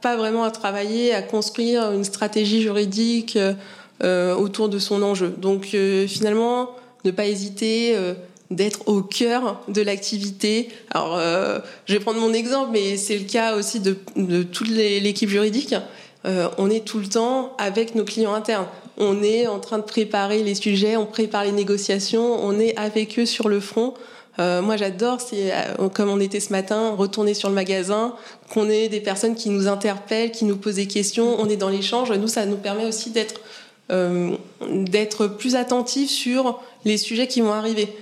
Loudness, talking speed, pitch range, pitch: -22 LUFS, 185 wpm, 200-225 Hz, 210 Hz